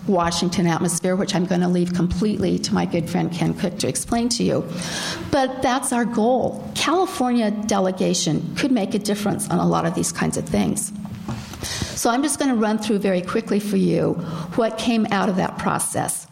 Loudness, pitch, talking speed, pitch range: -21 LUFS, 200 Hz, 195 wpm, 175-230 Hz